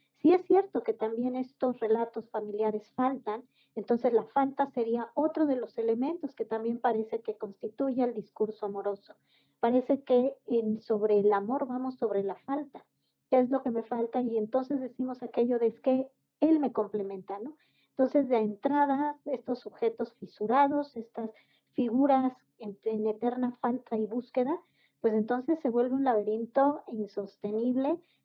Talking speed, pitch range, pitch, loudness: 155 wpm, 220-270 Hz, 245 Hz, -30 LUFS